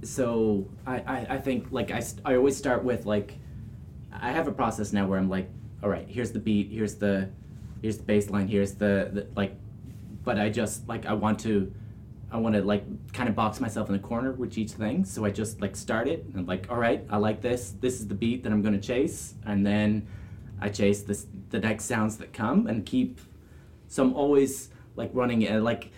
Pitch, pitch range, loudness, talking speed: 105 Hz, 100-120 Hz, -28 LUFS, 230 wpm